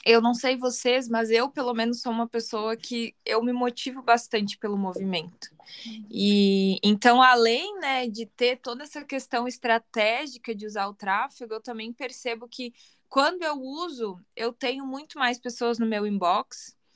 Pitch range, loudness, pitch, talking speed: 220-255 Hz, -25 LUFS, 235 Hz, 165 wpm